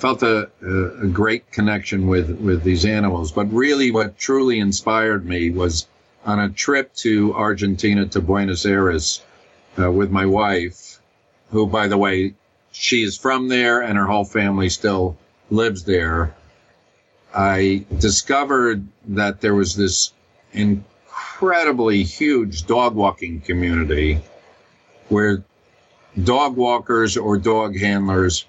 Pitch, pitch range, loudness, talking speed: 100 Hz, 95-110 Hz, -19 LUFS, 125 wpm